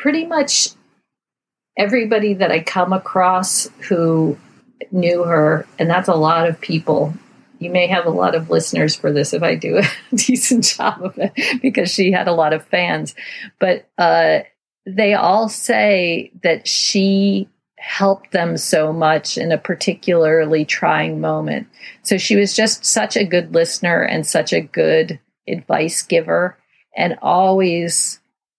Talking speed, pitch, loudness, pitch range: 150 wpm, 185 Hz, -16 LUFS, 165-210 Hz